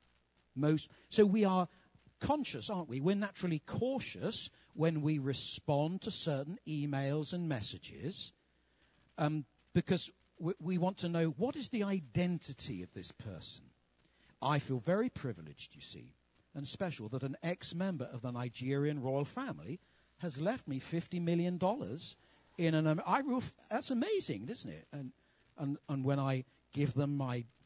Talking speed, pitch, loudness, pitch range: 150 wpm, 150 Hz, -37 LUFS, 135-185 Hz